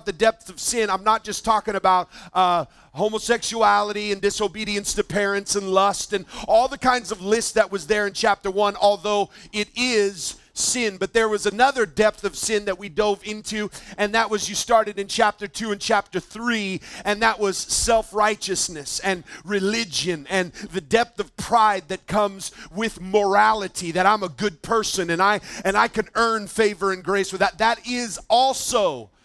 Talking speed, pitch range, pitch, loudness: 185 wpm, 195-220 Hz, 205 Hz, -22 LUFS